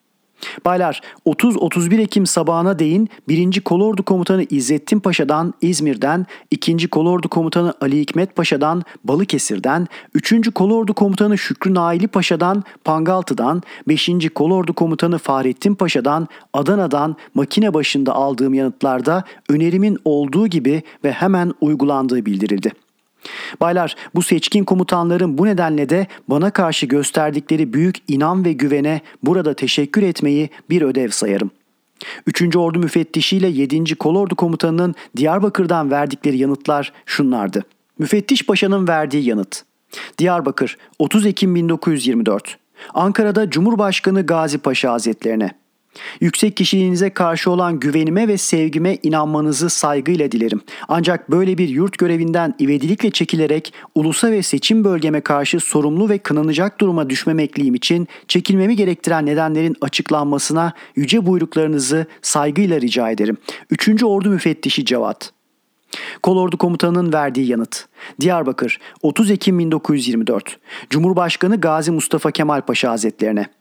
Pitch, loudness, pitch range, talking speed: 165 Hz, -17 LUFS, 145-185 Hz, 115 wpm